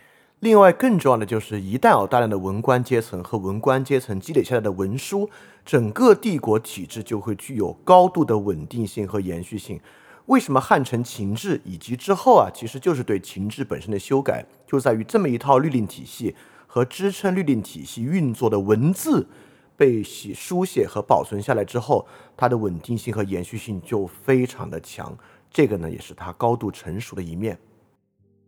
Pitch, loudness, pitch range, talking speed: 115 Hz, -21 LUFS, 100-135 Hz, 285 characters per minute